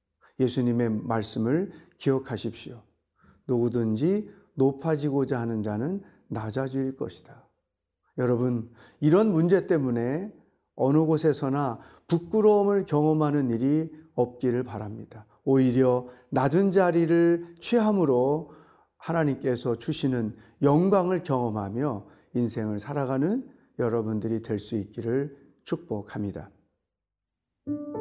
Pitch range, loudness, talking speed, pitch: 115-160 Hz, -26 LUFS, 245 characters per minute, 135 Hz